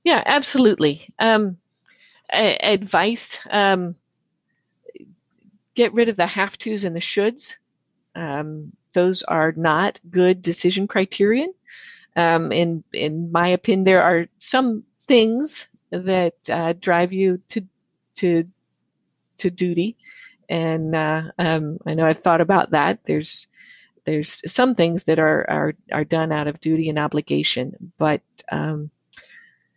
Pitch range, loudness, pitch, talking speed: 160-215 Hz, -20 LUFS, 180 Hz, 125 wpm